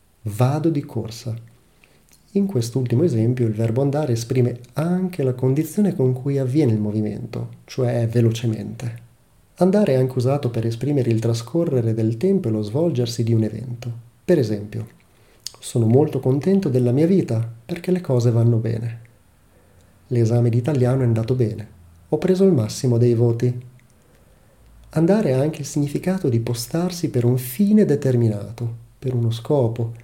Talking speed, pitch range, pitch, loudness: 150 wpm, 115-140 Hz, 120 Hz, -20 LUFS